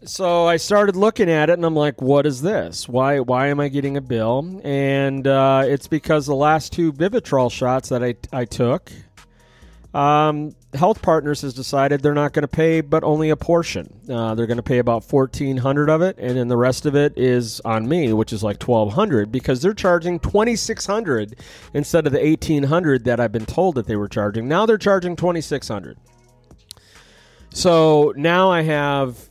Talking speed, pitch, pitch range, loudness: 205 wpm, 145 Hz, 125-165 Hz, -19 LUFS